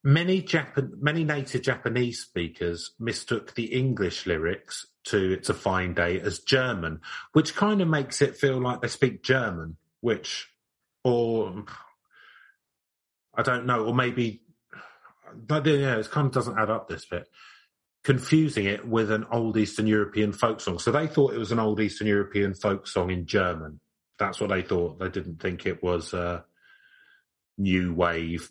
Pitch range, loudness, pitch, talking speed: 95-135 Hz, -26 LUFS, 115 Hz, 165 wpm